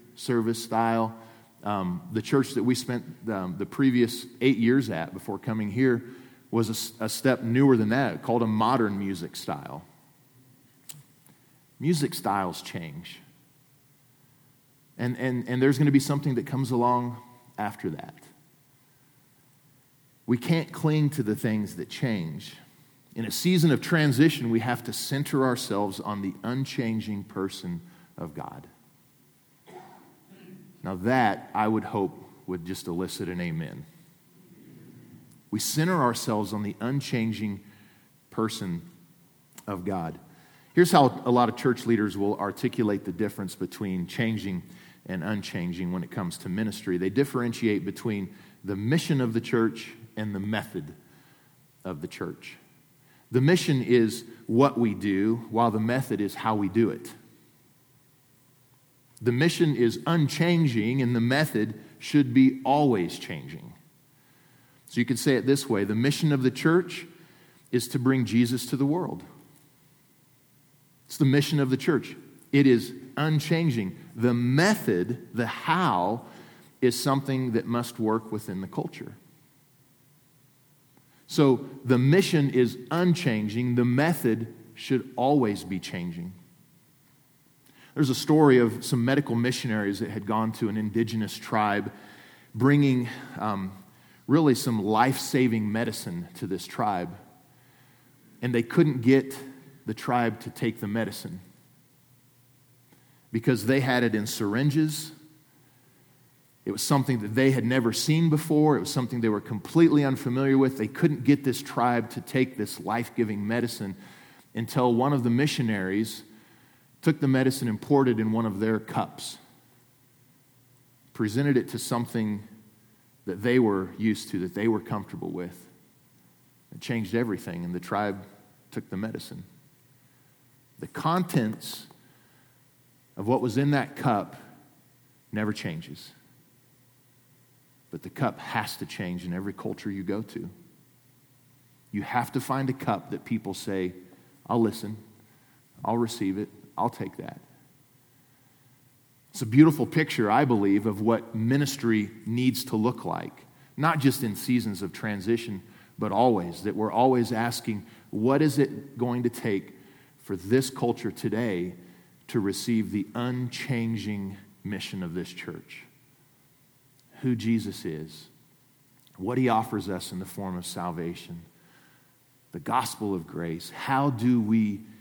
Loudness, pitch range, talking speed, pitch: -27 LUFS, 110-140 Hz, 140 wpm, 125 Hz